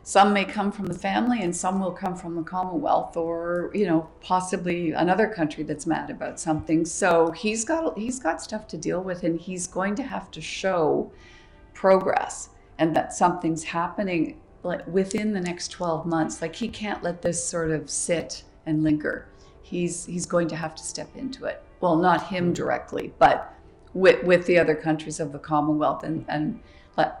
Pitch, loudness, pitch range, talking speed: 175 Hz, -25 LUFS, 160-190 Hz, 190 wpm